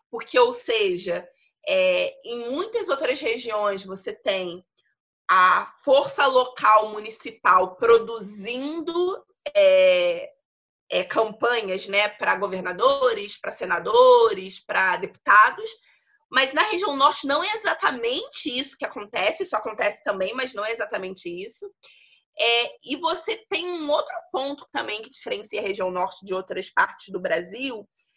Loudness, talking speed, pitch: -22 LUFS, 130 wpm, 275 Hz